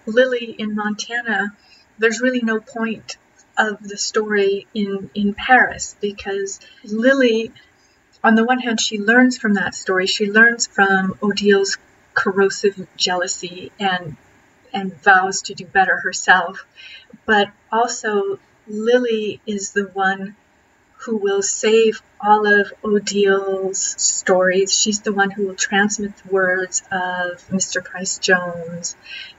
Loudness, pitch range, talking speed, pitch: -18 LUFS, 195-220 Hz, 125 wpm, 205 Hz